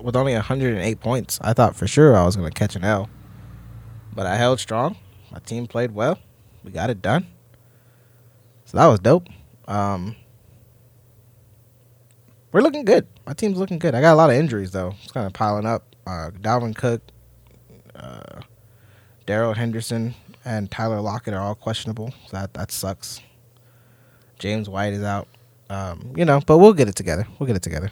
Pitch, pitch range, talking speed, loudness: 115 Hz, 105-120 Hz, 180 wpm, -20 LUFS